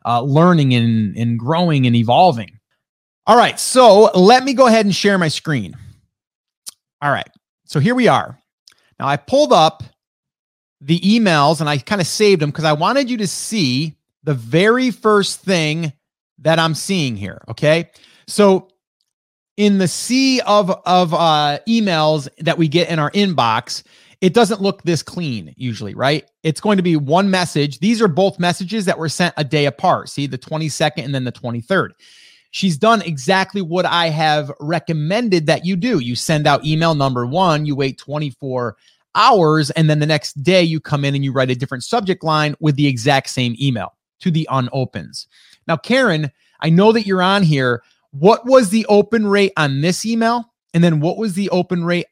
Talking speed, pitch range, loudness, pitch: 185 wpm, 145-195 Hz, -16 LUFS, 165 Hz